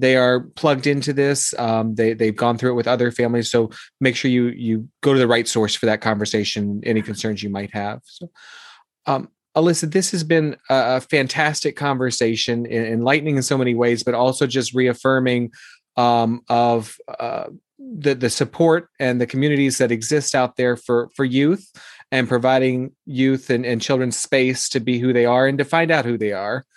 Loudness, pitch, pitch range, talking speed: -19 LUFS, 125 Hz, 120-140 Hz, 190 wpm